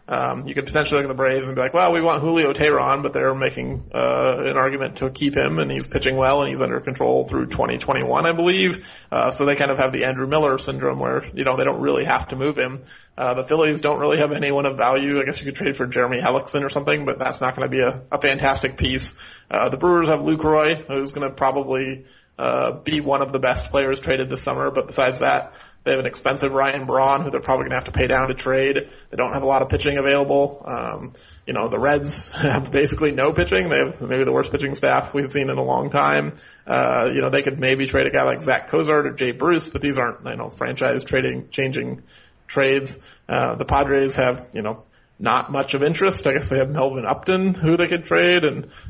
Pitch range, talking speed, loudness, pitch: 130-145 Hz, 245 wpm, -20 LUFS, 135 Hz